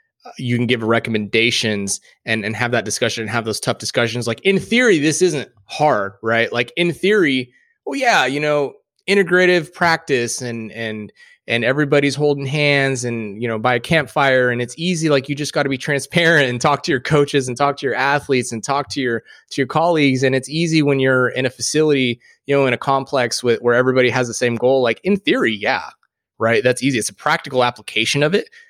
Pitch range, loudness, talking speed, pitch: 120-150 Hz, -17 LUFS, 215 wpm, 135 Hz